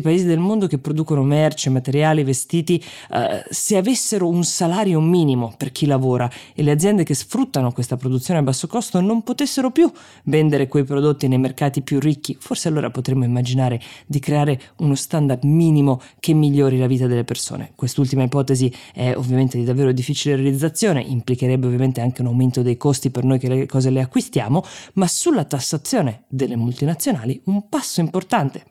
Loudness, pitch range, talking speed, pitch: -19 LUFS, 130-170 Hz, 170 wpm, 145 Hz